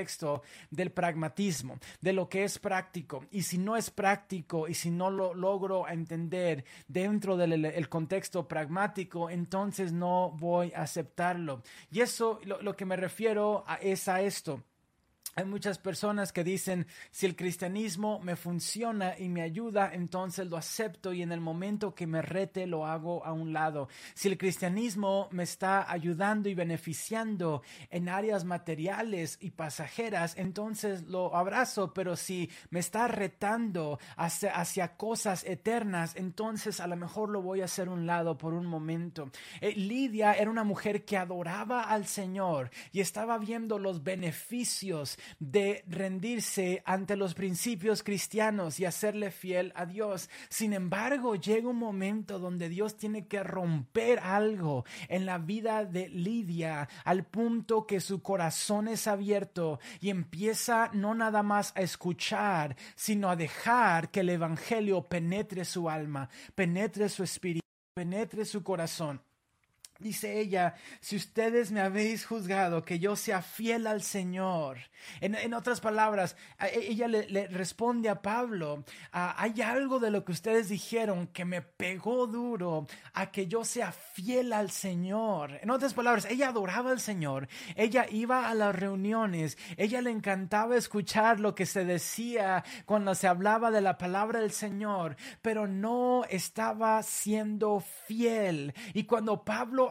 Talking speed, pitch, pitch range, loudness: 155 wpm, 195 Hz, 175-215 Hz, -32 LUFS